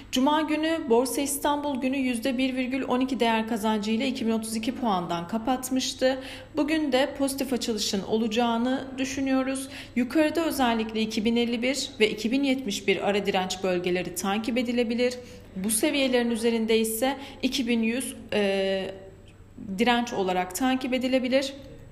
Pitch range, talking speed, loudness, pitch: 220-265 Hz, 100 wpm, -26 LUFS, 245 Hz